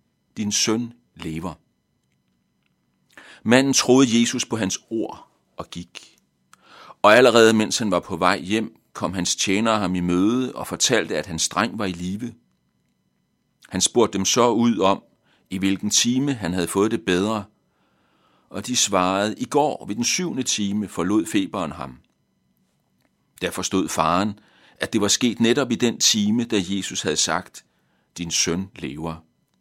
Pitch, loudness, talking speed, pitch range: 100 Hz, -21 LUFS, 155 wpm, 90-115 Hz